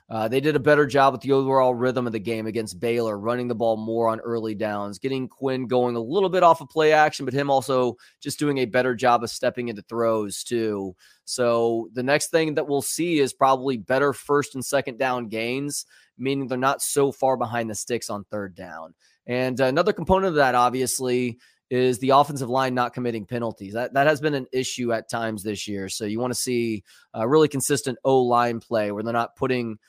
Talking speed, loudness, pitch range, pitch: 220 wpm, -23 LUFS, 115-135 Hz, 125 Hz